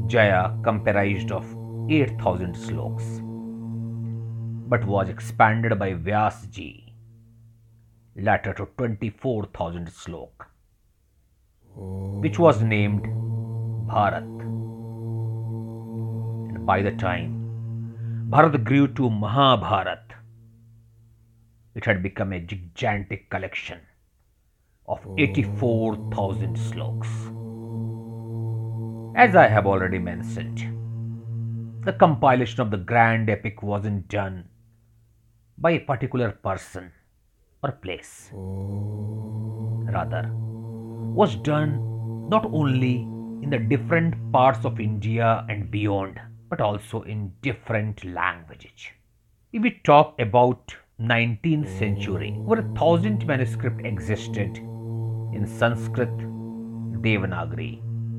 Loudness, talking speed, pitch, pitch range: -24 LUFS, 90 wpm, 115 Hz, 105-115 Hz